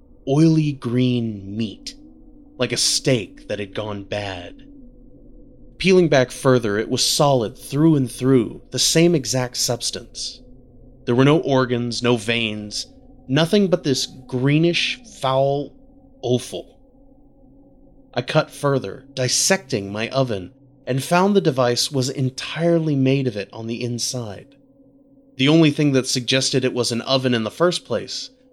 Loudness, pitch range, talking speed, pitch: -20 LUFS, 125-165 Hz, 140 wpm, 130 Hz